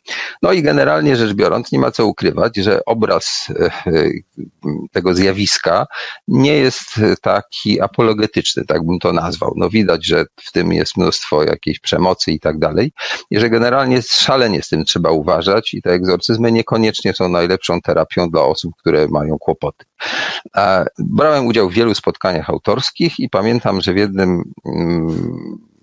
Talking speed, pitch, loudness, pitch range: 150 wpm, 100 Hz, -15 LUFS, 90-115 Hz